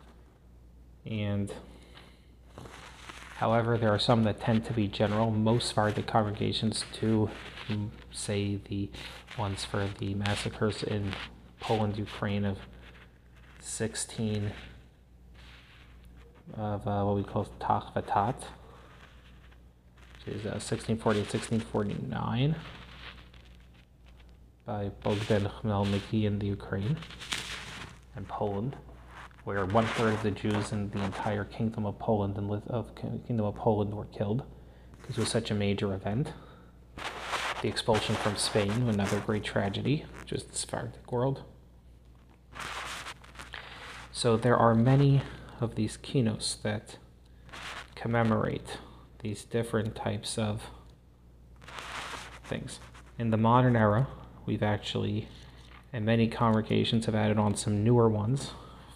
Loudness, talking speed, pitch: -31 LUFS, 115 wpm, 105 Hz